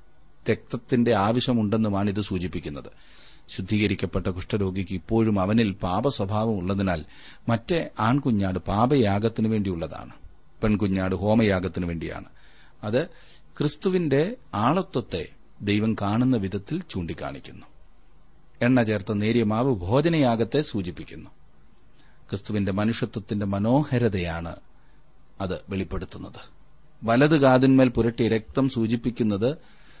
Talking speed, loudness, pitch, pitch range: 80 wpm, -25 LUFS, 110 Hz, 100-125 Hz